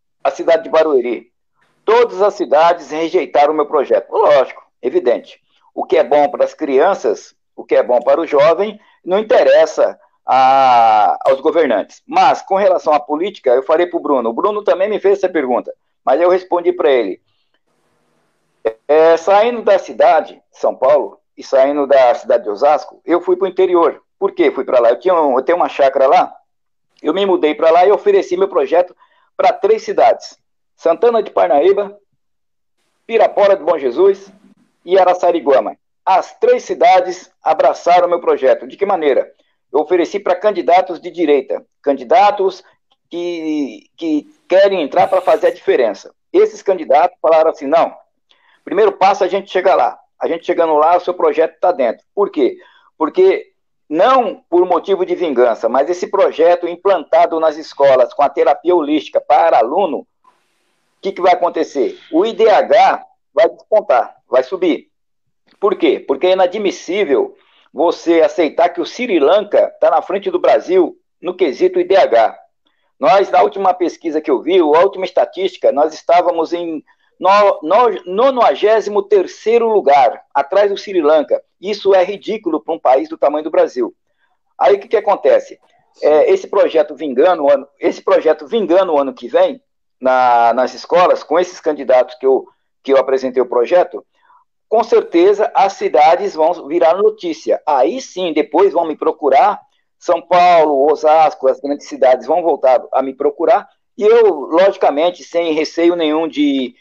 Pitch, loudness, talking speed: 200 Hz, -14 LUFS, 165 wpm